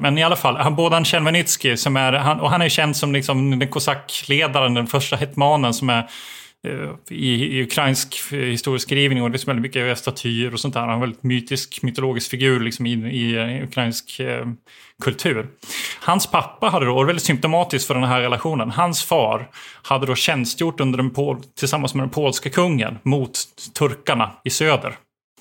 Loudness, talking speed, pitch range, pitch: -20 LUFS, 180 wpm, 125-145 Hz, 135 Hz